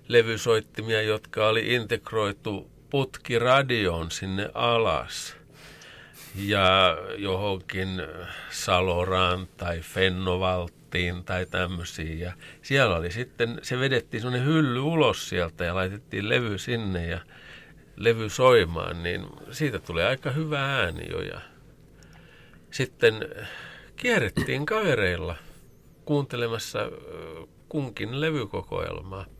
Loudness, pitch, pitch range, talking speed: -26 LUFS, 105 Hz, 90-130 Hz, 90 wpm